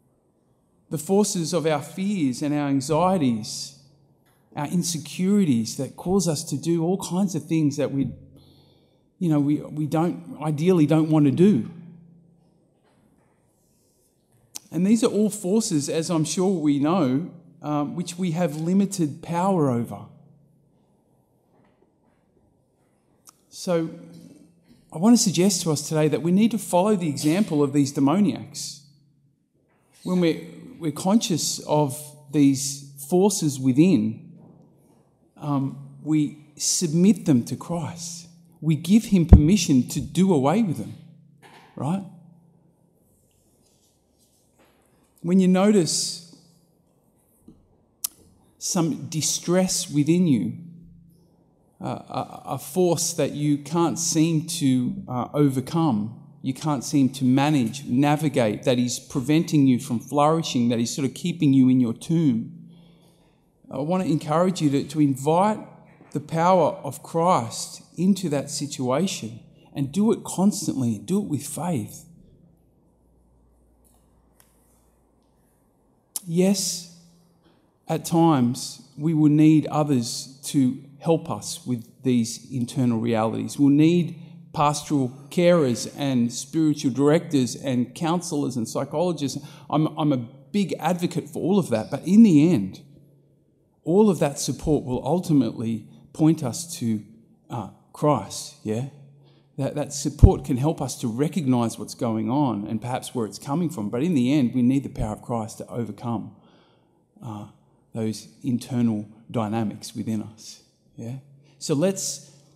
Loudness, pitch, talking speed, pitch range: -23 LUFS, 150 Hz, 125 wpm, 135-170 Hz